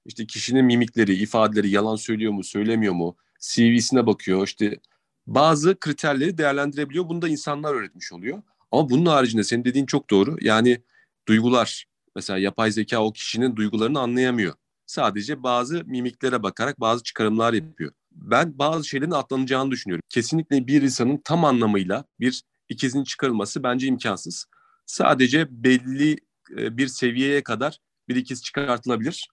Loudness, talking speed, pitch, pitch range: -22 LUFS, 135 wpm, 125 Hz, 110-140 Hz